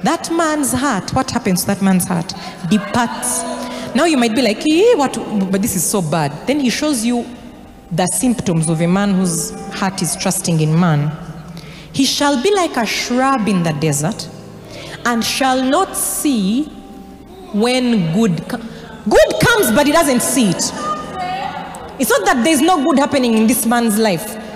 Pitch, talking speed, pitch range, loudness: 225 Hz, 175 wpm, 185-270 Hz, -16 LUFS